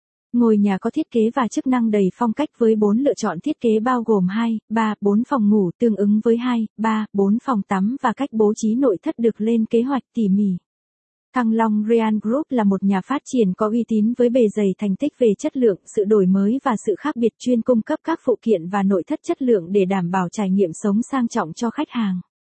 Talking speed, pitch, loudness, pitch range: 245 wpm, 225 Hz, -20 LUFS, 205-250 Hz